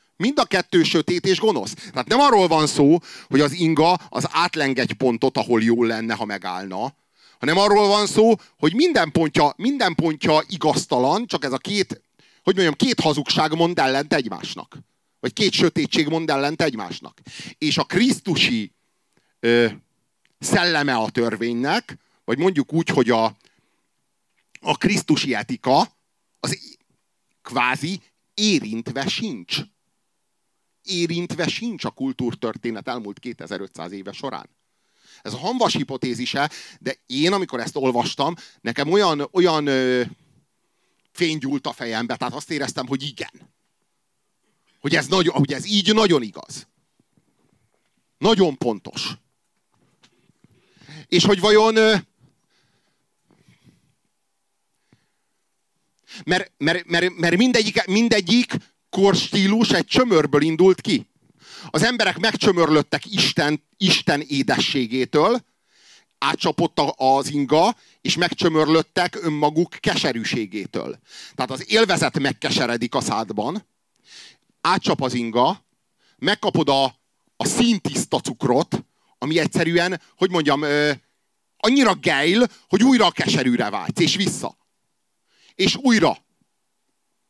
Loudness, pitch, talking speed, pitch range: -20 LUFS, 160 Hz, 115 wpm, 135-195 Hz